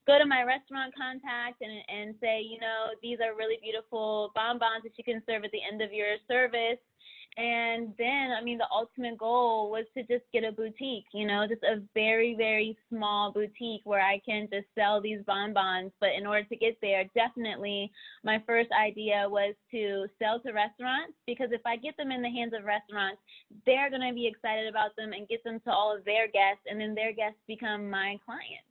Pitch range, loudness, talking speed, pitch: 210-235 Hz, -30 LUFS, 210 wpm, 220 Hz